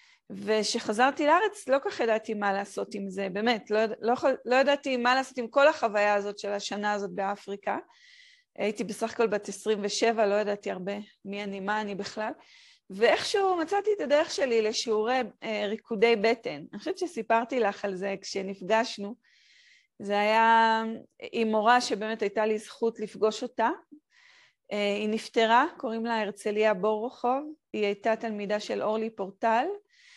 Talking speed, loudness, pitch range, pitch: 155 wpm, -28 LUFS, 210-260 Hz, 225 Hz